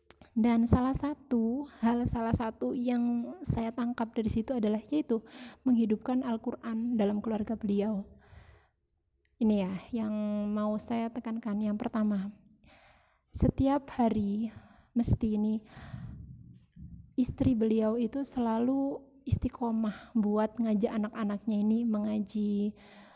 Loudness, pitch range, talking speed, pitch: -31 LUFS, 215-240 Hz, 105 wpm, 225 Hz